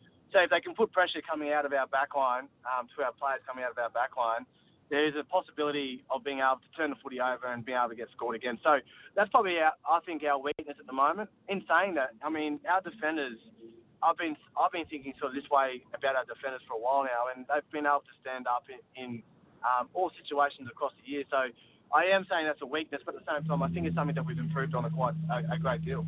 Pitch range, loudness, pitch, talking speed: 130-160 Hz, -31 LUFS, 145 Hz, 260 wpm